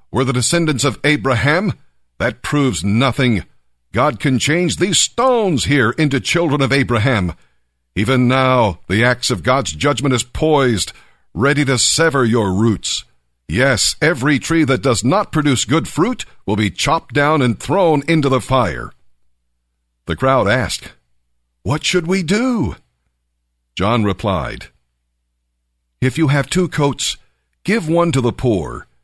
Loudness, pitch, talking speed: -16 LUFS, 125 Hz, 145 wpm